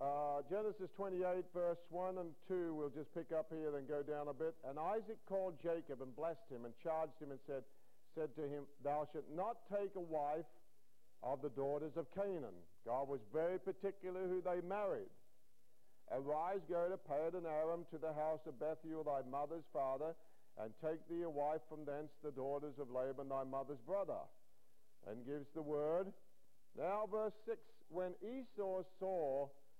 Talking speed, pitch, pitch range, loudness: 175 wpm, 160 Hz, 145-185 Hz, -45 LUFS